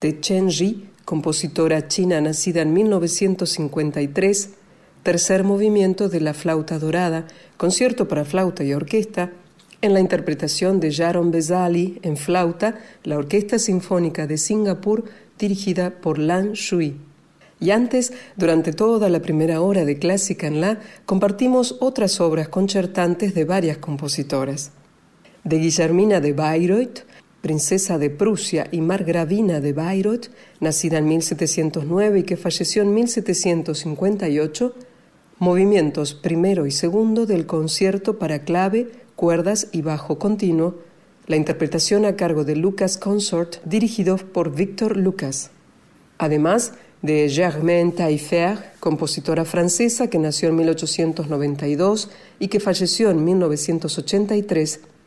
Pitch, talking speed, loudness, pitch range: 180 Hz, 120 wpm, -20 LUFS, 160-200 Hz